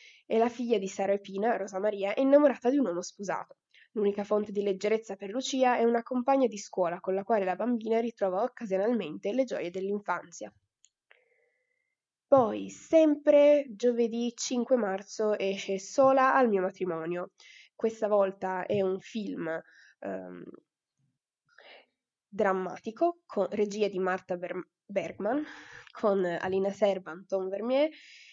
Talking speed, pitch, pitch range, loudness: 135 wpm, 205 Hz, 190-245 Hz, -29 LUFS